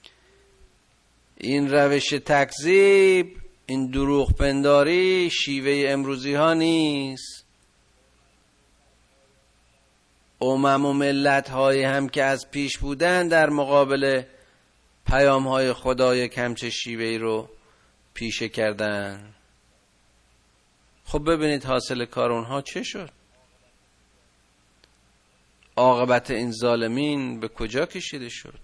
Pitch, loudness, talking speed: 130 Hz, -22 LUFS, 90 wpm